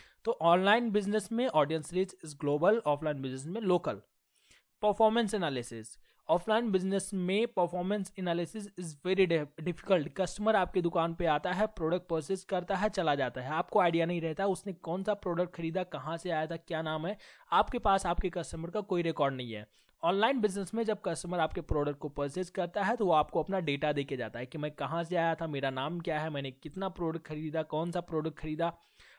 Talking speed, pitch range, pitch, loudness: 200 wpm, 155-195 Hz, 175 Hz, -32 LUFS